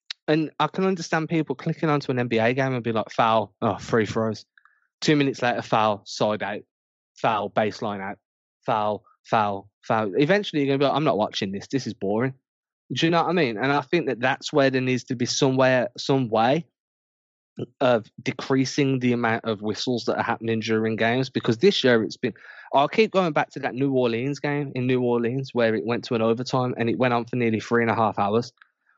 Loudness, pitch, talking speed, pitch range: -23 LUFS, 125 Hz, 220 wpm, 110-140 Hz